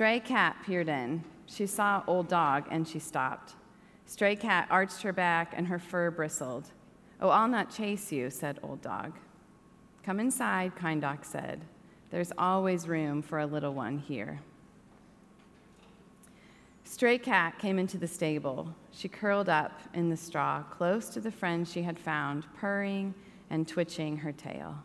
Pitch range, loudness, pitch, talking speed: 155-200 Hz, -31 LUFS, 175 Hz, 155 wpm